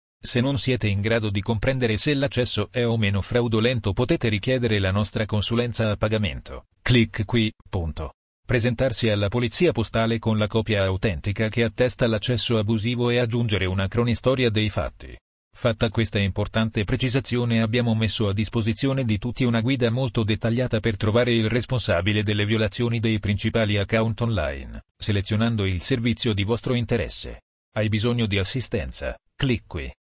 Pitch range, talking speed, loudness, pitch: 105-120 Hz, 155 wpm, -23 LUFS, 115 Hz